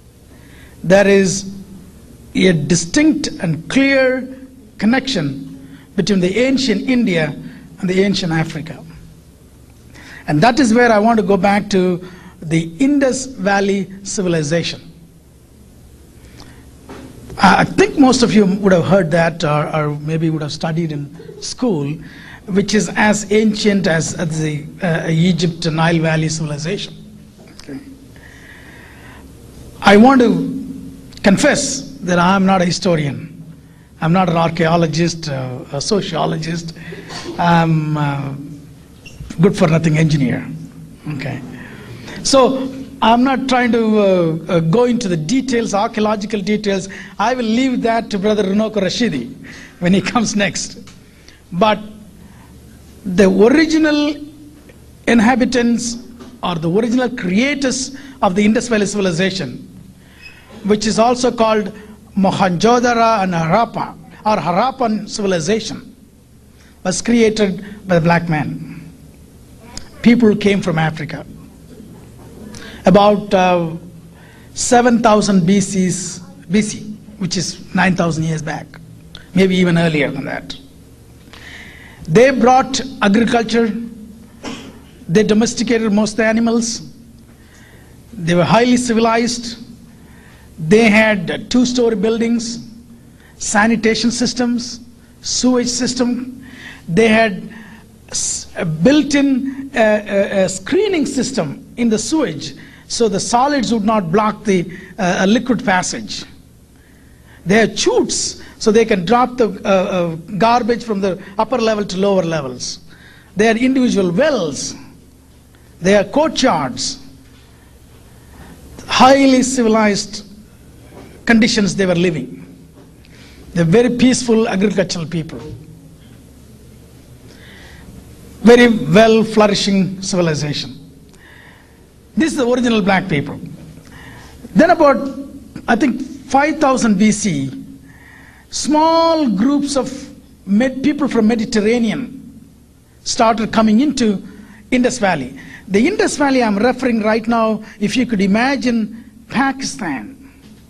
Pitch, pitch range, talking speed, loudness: 210 Hz, 170-235 Hz, 110 wpm, -15 LUFS